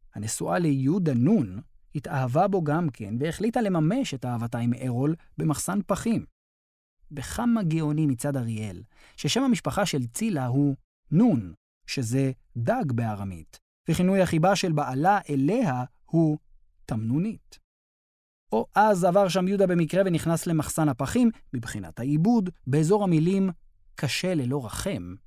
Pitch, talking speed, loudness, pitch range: 150 Hz, 120 wpm, -26 LUFS, 130-190 Hz